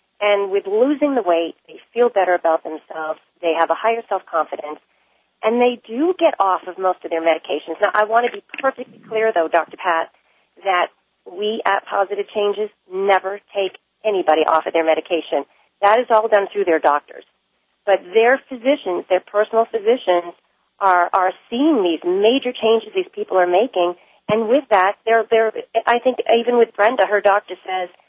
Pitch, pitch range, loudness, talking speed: 205 Hz, 180-230 Hz, -18 LUFS, 180 wpm